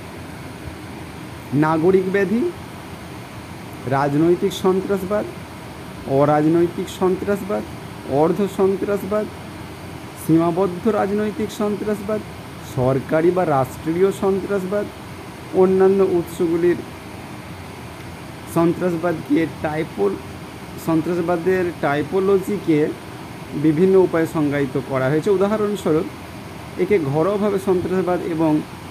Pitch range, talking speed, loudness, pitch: 160-195 Hz, 65 wpm, -20 LUFS, 180 Hz